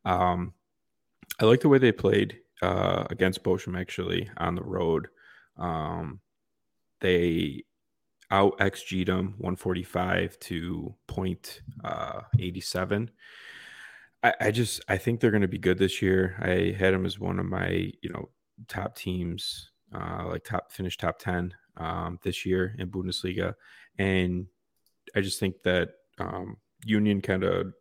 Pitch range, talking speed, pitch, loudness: 90-100 Hz, 150 wpm, 95 Hz, -28 LUFS